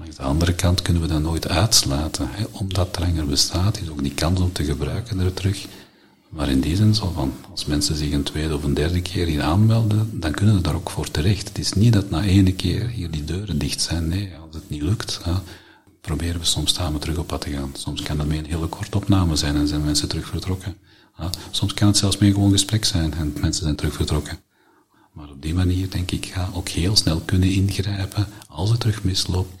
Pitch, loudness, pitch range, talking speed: 90 Hz, -21 LUFS, 75-100 Hz, 235 wpm